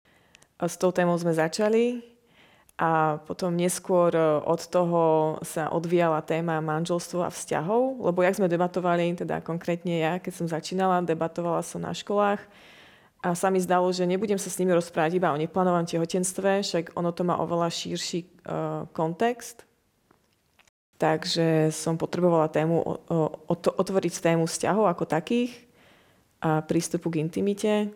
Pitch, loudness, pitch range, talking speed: 175 Hz, -26 LUFS, 165-185 Hz, 140 wpm